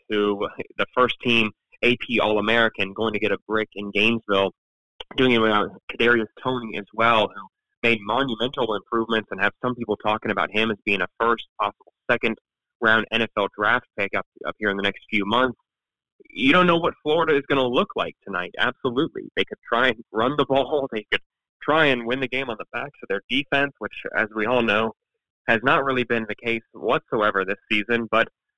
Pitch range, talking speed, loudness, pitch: 105-125 Hz, 200 wpm, -22 LUFS, 115 Hz